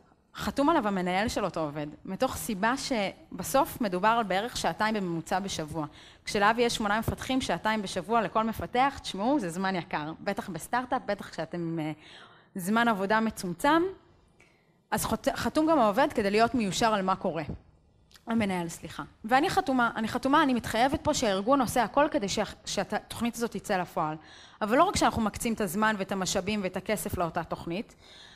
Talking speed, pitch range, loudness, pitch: 160 wpm, 180-240 Hz, -28 LUFS, 210 Hz